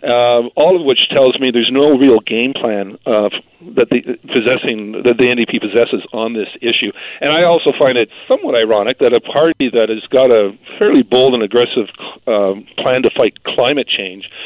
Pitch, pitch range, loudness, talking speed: 120 Hz, 115-150 Hz, -13 LUFS, 195 wpm